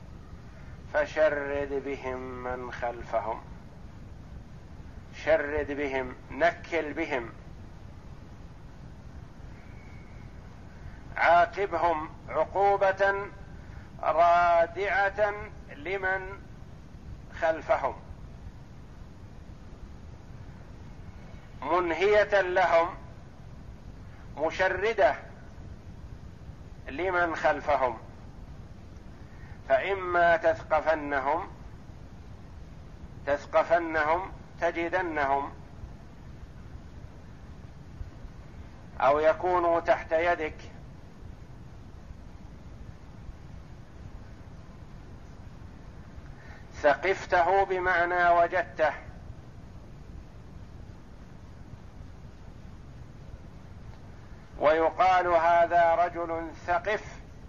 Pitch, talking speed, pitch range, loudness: 155 Hz, 35 wpm, 120-175 Hz, -27 LUFS